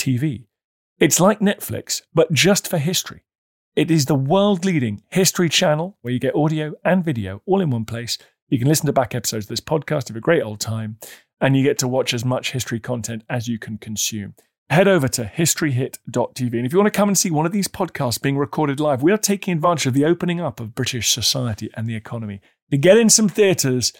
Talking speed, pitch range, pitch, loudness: 225 wpm, 120-175 Hz, 140 Hz, -19 LUFS